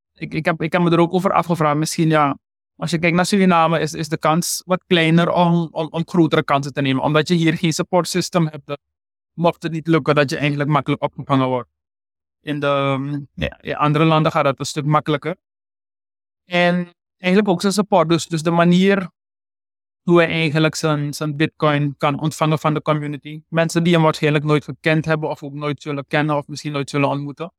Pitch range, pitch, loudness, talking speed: 145-170 Hz, 155 Hz, -18 LUFS, 205 wpm